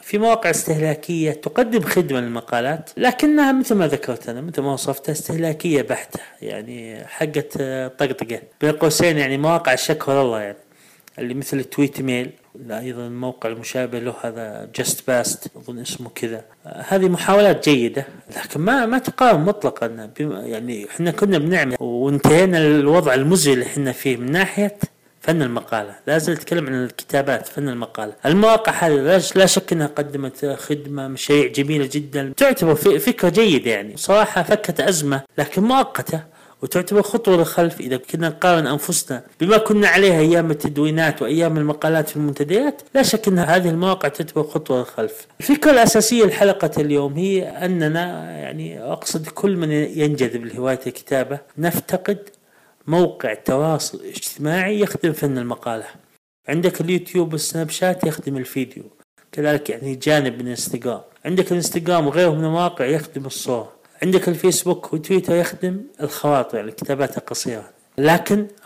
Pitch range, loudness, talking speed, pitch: 135-180 Hz, -19 LUFS, 140 wpm, 155 Hz